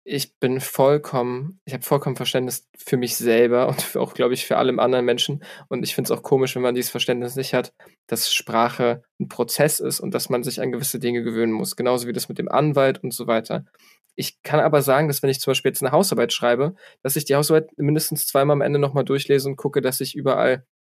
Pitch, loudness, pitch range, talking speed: 130 Hz, -21 LUFS, 125-140 Hz, 235 wpm